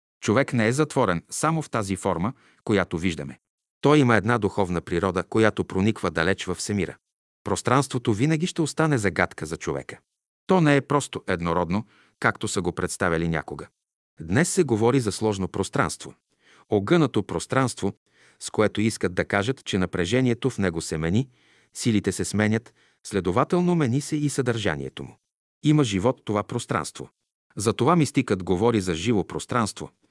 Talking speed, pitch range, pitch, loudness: 150 wpm, 95-135 Hz, 110 Hz, -24 LUFS